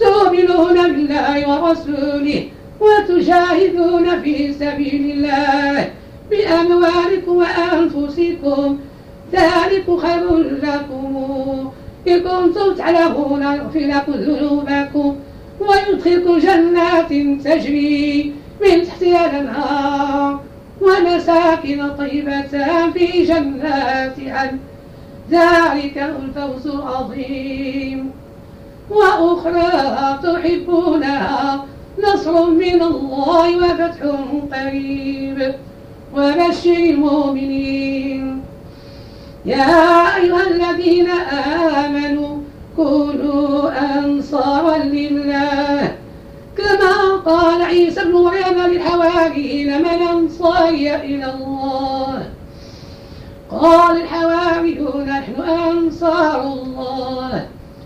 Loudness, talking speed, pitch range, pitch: -15 LUFS, 65 wpm, 280-345 Hz, 300 Hz